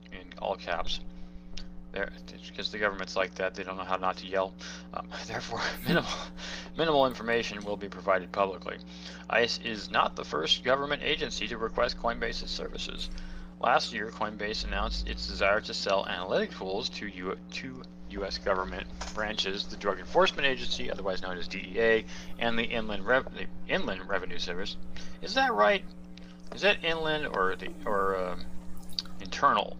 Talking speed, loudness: 155 wpm, -30 LUFS